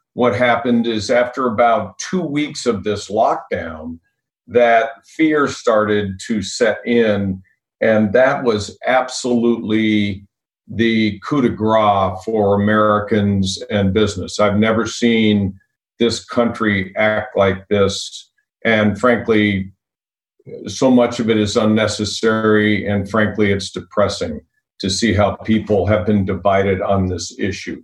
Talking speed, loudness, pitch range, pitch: 125 wpm, -17 LUFS, 100-115 Hz, 105 Hz